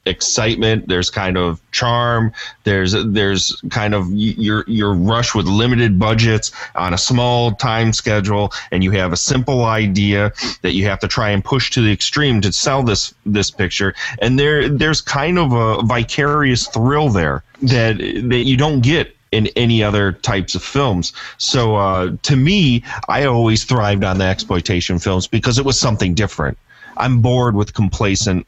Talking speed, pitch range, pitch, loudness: 170 wpm, 100-125 Hz, 110 Hz, -16 LUFS